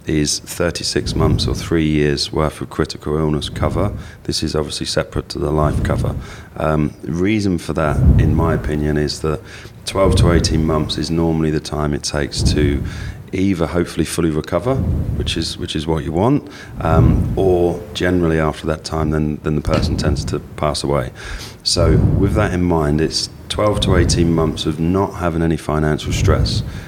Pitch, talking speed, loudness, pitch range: 80 Hz, 180 wpm, -18 LUFS, 75-95 Hz